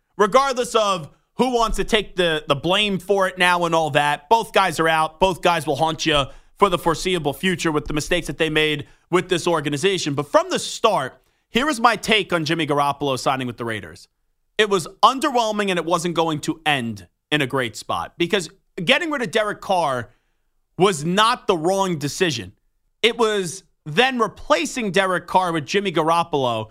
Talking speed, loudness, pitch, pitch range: 190 wpm, -20 LUFS, 175 Hz, 150-205 Hz